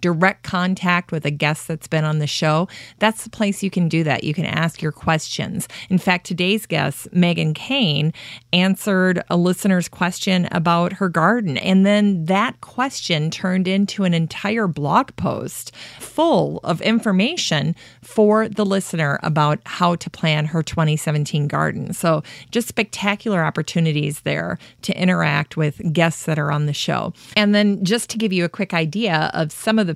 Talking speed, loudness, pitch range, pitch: 170 wpm, -19 LUFS, 155-200 Hz, 175 Hz